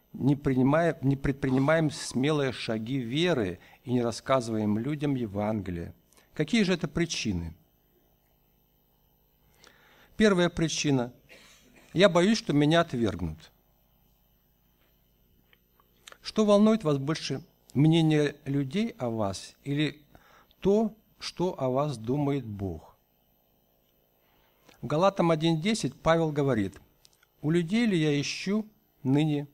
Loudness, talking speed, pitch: -27 LUFS, 100 wpm, 135 Hz